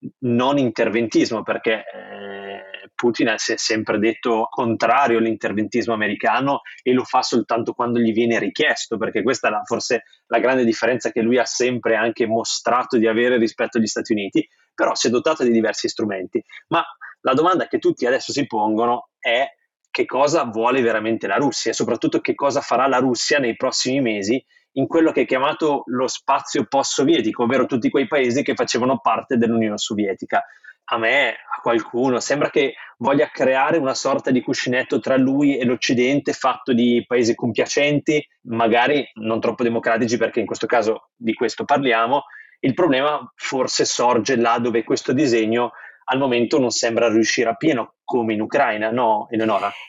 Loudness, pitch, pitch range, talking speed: -20 LUFS, 120 Hz, 115-135 Hz, 170 wpm